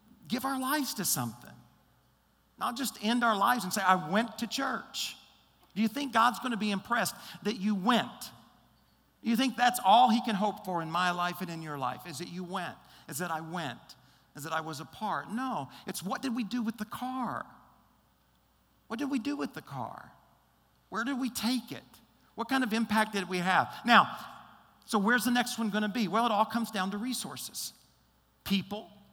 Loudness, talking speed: -31 LUFS, 205 wpm